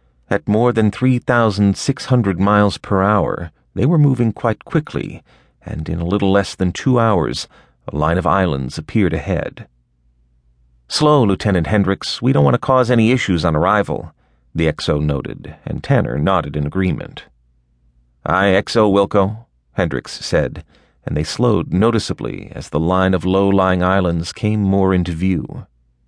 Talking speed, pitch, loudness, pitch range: 155 wpm, 95 Hz, -17 LUFS, 75-105 Hz